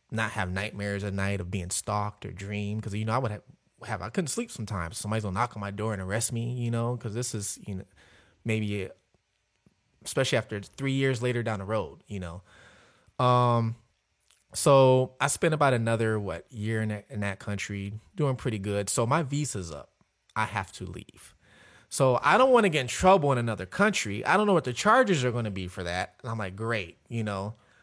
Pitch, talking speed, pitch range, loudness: 110 Hz, 220 wpm, 100-125 Hz, -28 LUFS